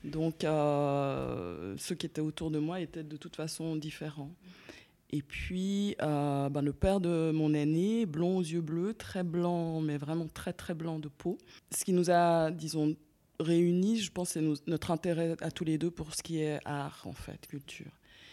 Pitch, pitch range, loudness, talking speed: 160 Hz, 150-175 Hz, -33 LUFS, 195 wpm